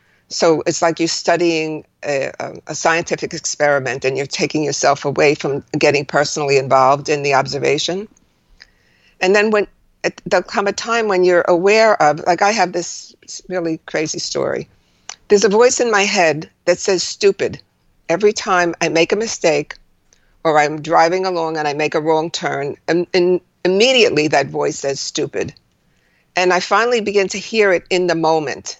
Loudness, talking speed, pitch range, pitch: -16 LUFS, 170 wpm, 155-200 Hz, 175 Hz